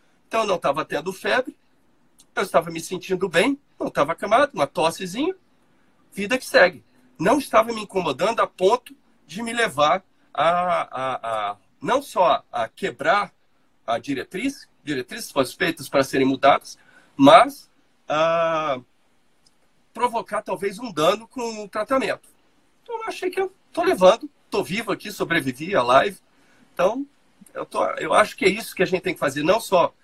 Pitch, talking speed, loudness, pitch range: 210 Hz, 160 wpm, -22 LUFS, 180-275 Hz